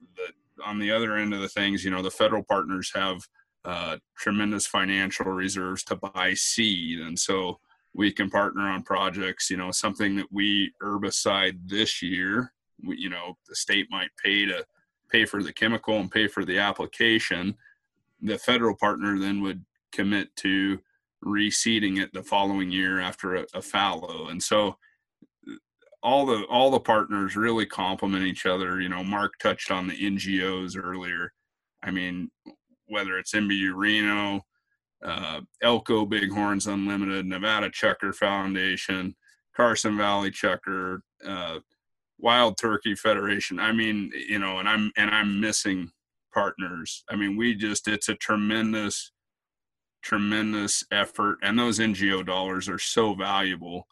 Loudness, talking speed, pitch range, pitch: -26 LUFS, 150 wpm, 95-105 Hz, 100 Hz